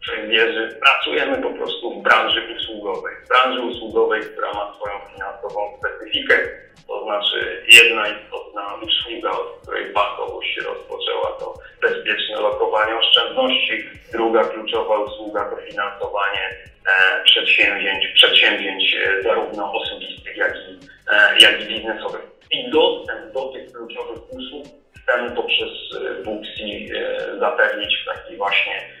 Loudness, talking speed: -17 LUFS, 120 wpm